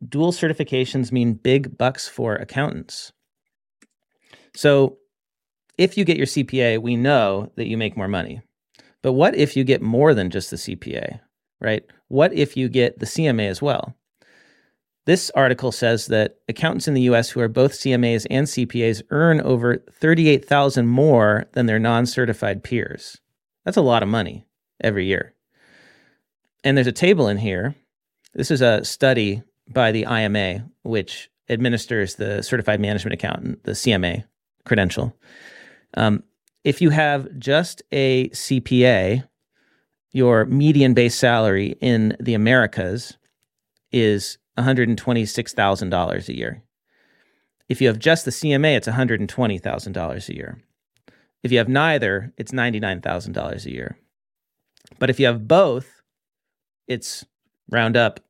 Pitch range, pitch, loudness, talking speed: 110-135 Hz, 125 Hz, -20 LUFS, 140 wpm